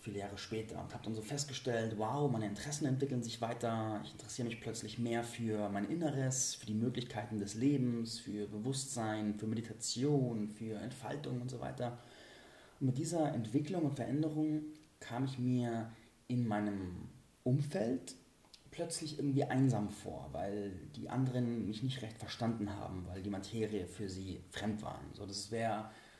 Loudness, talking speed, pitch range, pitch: -39 LUFS, 160 wpm, 105-130 Hz, 115 Hz